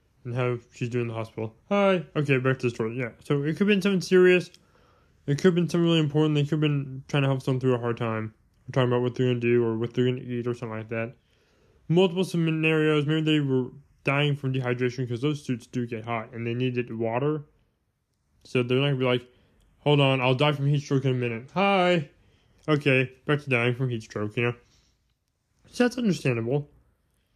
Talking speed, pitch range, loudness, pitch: 235 wpm, 120-150 Hz, -25 LUFS, 130 Hz